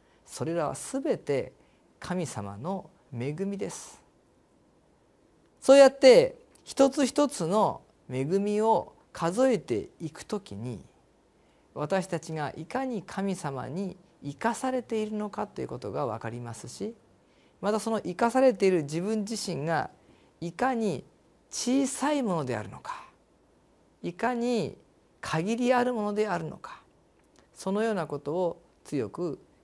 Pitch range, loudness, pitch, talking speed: 160-235 Hz, -28 LUFS, 200 Hz, 245 characters per minute